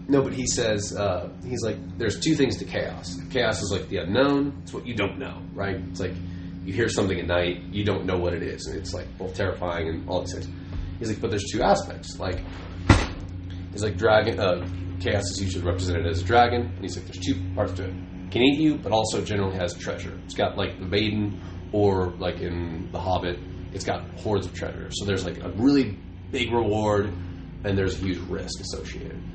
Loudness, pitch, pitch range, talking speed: -26 LUFS, 90 Hz, 90-100 Hz, 220 wpm